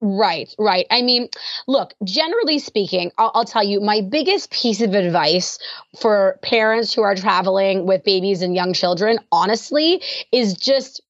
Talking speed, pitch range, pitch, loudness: 155 wpm, 195-245 Hz, 215 Hz, -18 LUFS